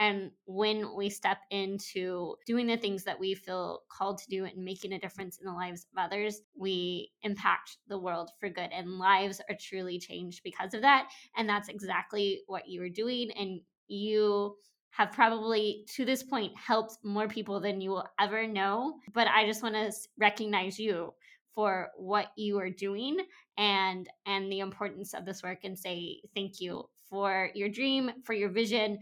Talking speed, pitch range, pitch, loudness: 180 wpm, 190-215 Hz, 200 Hz, -32 LUFS